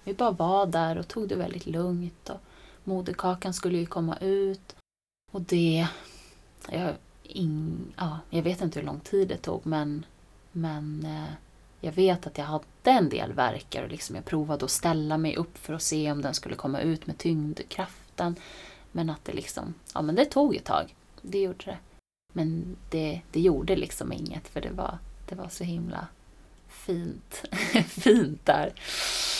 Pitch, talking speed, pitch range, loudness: 170 Hz, 175 wpm, 155-190 Hz, -29 LUFS